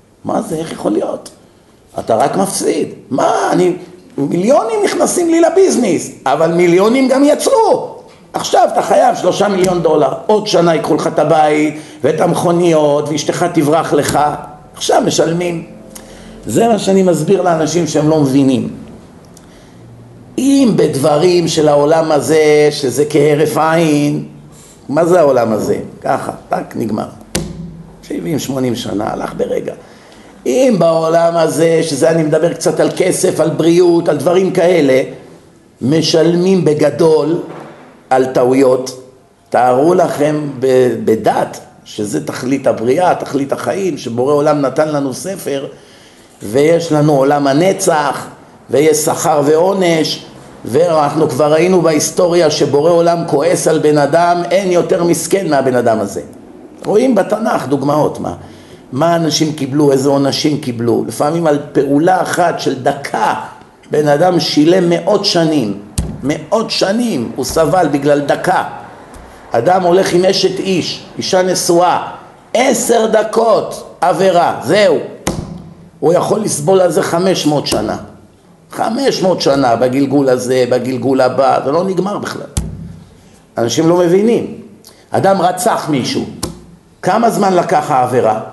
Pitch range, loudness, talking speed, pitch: 145-180 Hz, -13 LUFS, 125 wpm, 160 Hz